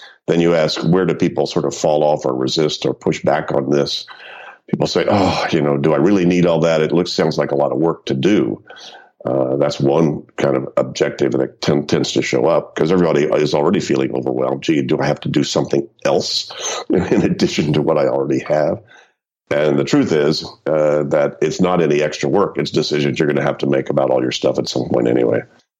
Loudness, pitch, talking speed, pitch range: -17 LUFS, 75 Hz, 230 wpm, 70-80 Hz